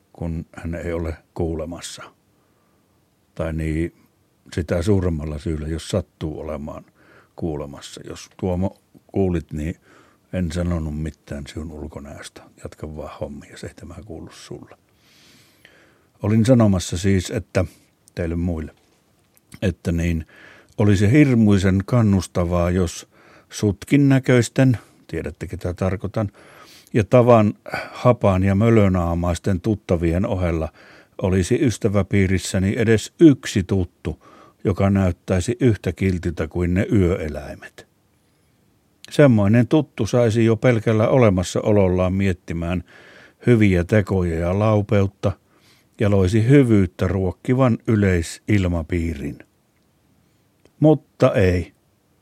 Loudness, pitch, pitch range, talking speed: -20 LUFS, 95 Hz, 85-110 Hz, 95 wpm